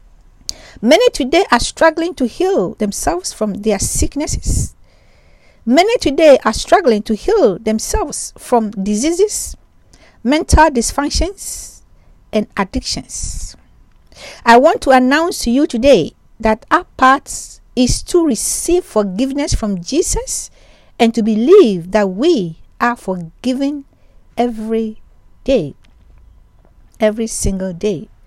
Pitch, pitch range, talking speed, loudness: 250 Hz, 220-320 Hz, 110 wpm, -15 LUFS